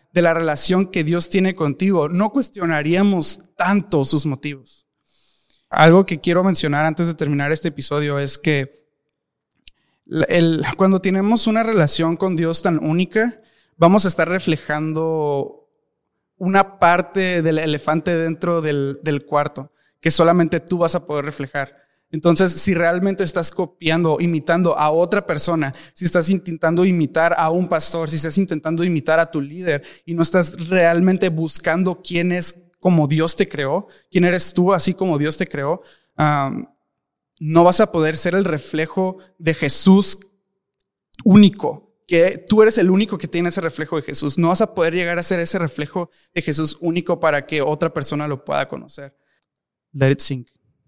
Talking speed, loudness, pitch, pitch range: 160 wpm, -16 LUFS, 170 Hz, 155-185 Hz